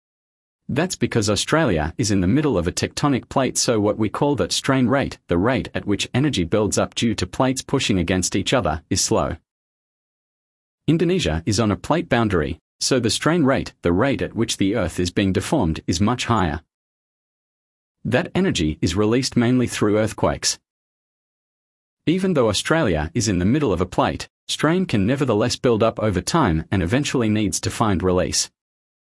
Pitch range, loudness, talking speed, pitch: 95-125 Hz, -20 LUFS, 175 wpm, 110 Hz